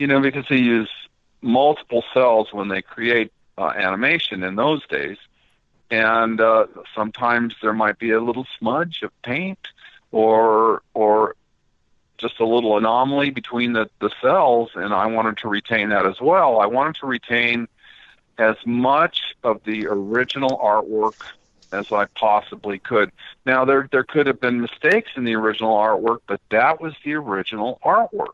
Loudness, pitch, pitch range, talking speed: -19 LUFS, 115 Hz, 110-130 Hz, 160 wpm